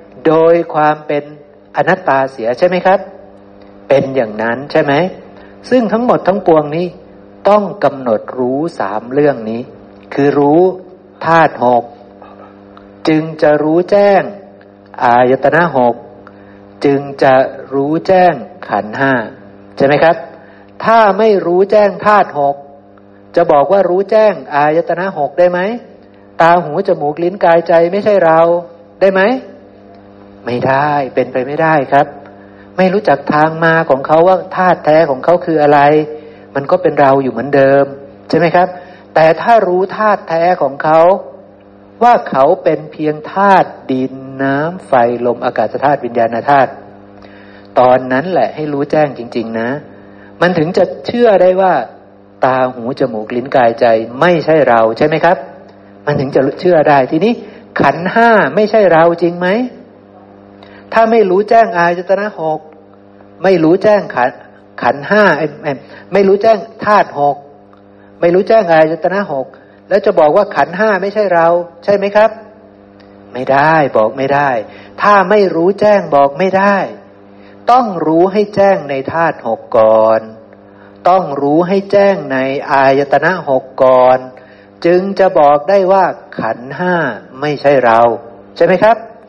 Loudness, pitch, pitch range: -11 LUFS, 145 Hz, 120-180 Hz